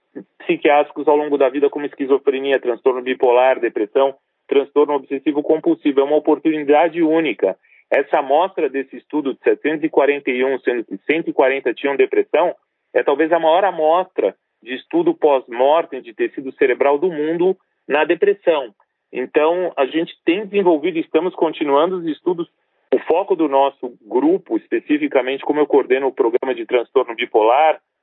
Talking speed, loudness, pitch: 145 wpm, -18 LUFS, 165 Hz